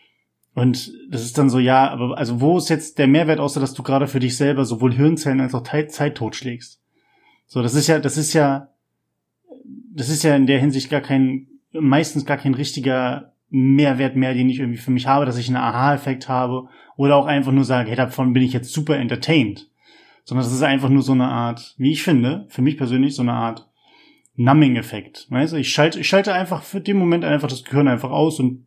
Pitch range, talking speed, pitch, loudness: 130-150 Hz, 220 wpm, 135 Hz, -19 LUFS